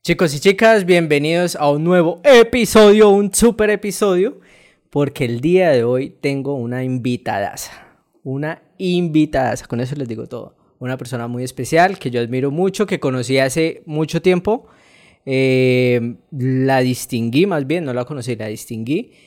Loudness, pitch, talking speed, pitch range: -16 LUFS, 145 Hz, 155 wpm, 125-180 Hz